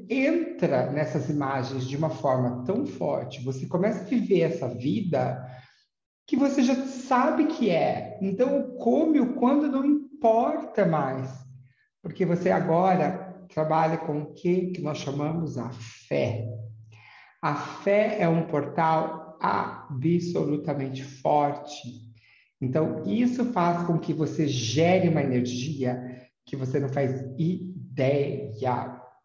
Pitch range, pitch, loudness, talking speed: 135-195 Hz, 155 Hz, -26 LUFS, 125 wpm